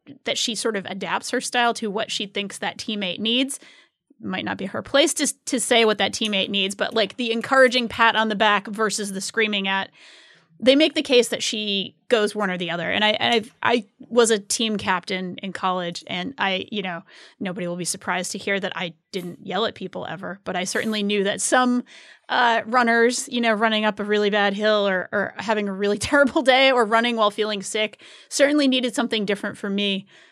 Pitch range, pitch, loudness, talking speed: 200-240 Hz, 215 Hz, -21 LUFS, 220 wpm